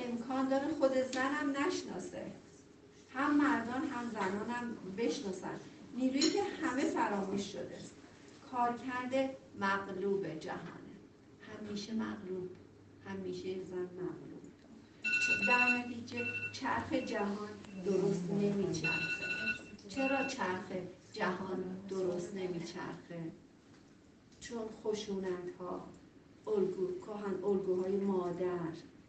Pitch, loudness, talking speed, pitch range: 210 Hz, -36 LUFS, 85 wpm, 185-260 Hz